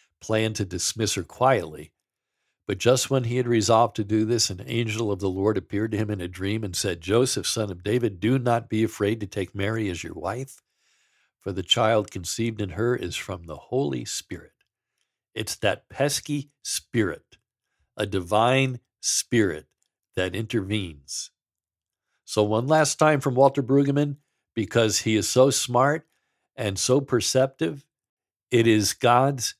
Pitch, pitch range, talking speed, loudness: 110 Hz, 105-125 Hz, 160 wpm, -24 LUFS